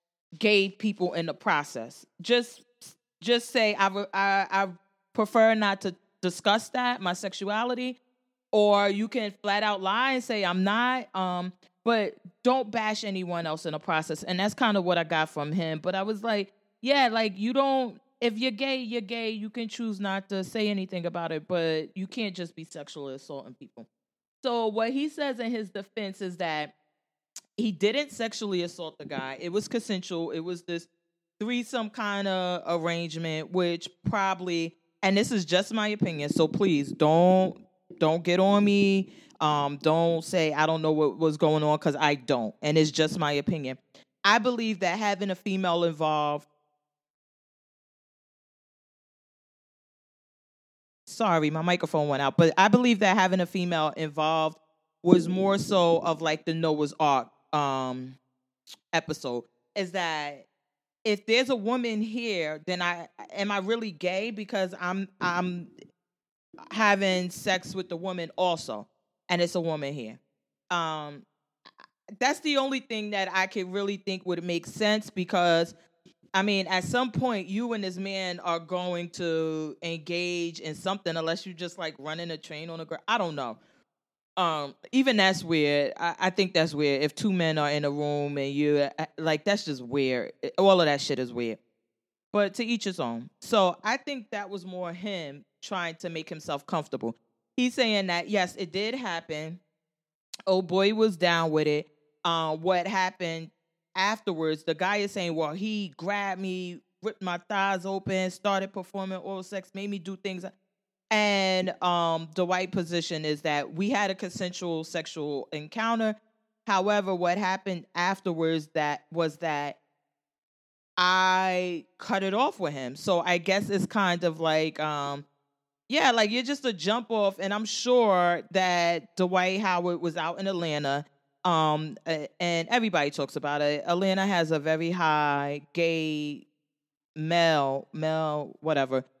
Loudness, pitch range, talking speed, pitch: -27 LUFS, 160-200 Hz, 165 wpm, 180 Hz